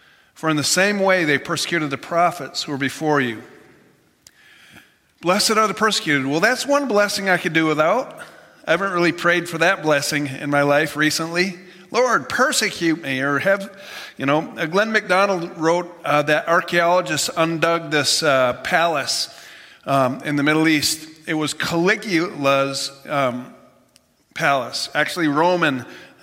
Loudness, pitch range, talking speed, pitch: -19 LUFS, 145-180 Hz, 150 wpm, 165 Hz